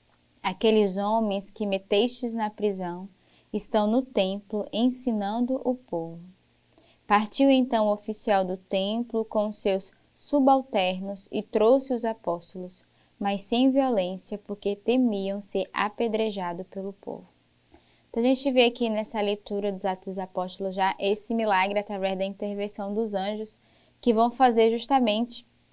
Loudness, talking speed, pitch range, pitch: -26 LUFS, 135 wpm, 195-230 Hz, 210 Hz